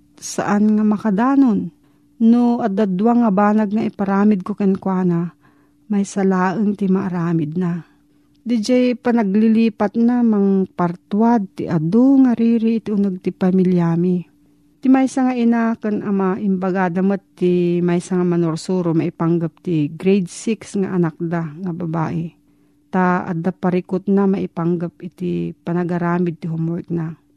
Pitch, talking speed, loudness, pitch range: 185 Hz, 130 wpm, -18 LUFS, 170-210 Hz